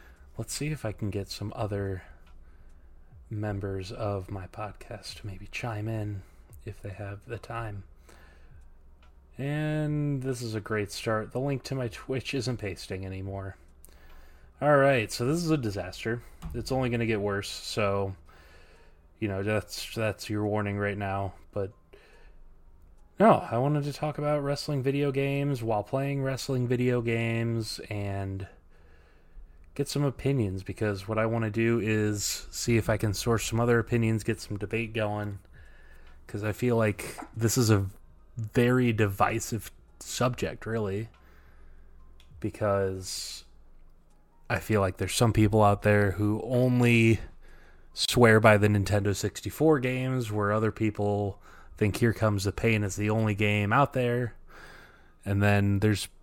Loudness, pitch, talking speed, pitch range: -28 LUFS, 105 Hz, 150 wpm, 90-115 Hz